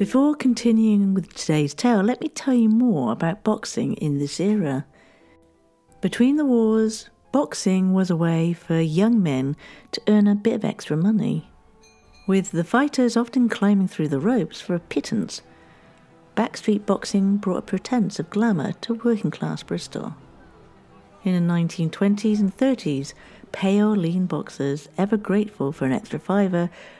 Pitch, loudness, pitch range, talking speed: 200 Hz, -22 LUFS, 165-225 Hz, 150 wpm